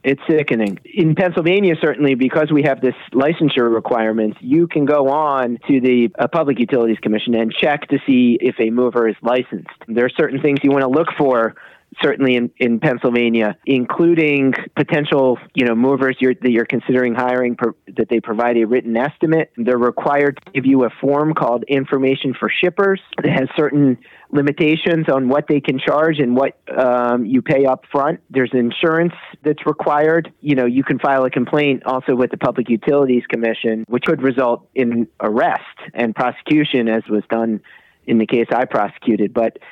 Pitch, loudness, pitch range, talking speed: 130 Hz, -17 LUFS, 120-150 Hz, 180 wpm